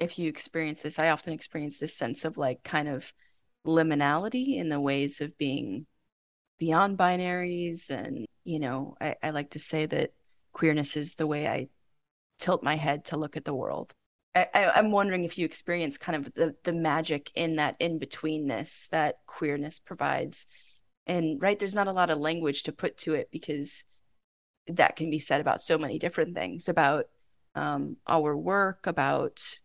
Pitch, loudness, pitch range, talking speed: 155 Hz, -29 LUFS, 150-170 Hz, 180 wpm